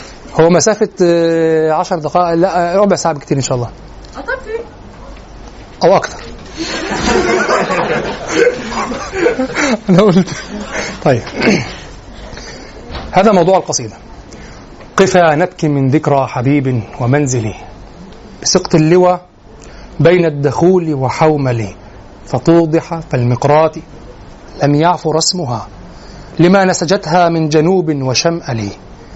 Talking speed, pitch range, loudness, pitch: 80 wpm, 130-180 Hz, -13 LUFS, 160 Hz